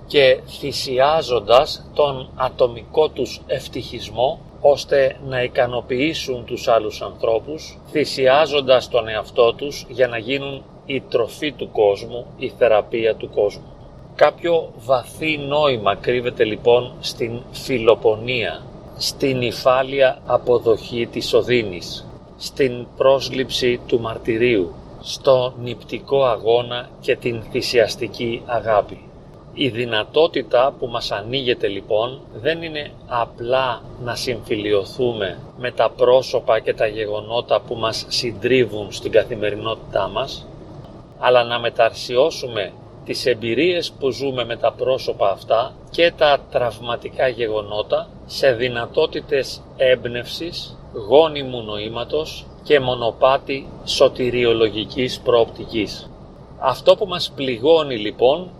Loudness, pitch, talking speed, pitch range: -19 LUFS, 130 Hz, 105 wpm, 120-155 Hz